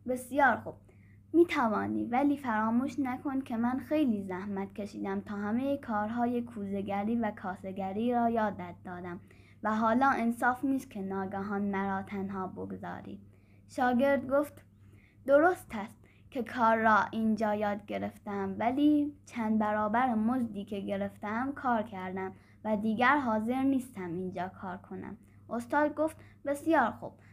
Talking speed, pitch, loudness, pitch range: 130 wpm, 220 Hz, -31 LUFS, 195-255 Hz